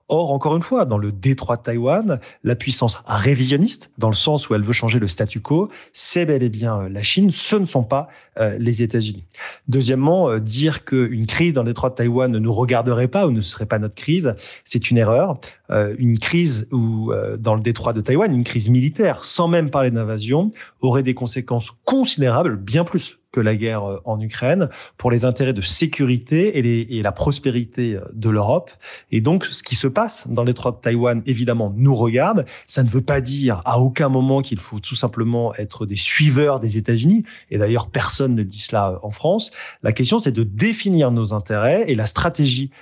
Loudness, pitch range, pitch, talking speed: -19 LUFS, 110-140 Hz, 125 Hz, 205 wpm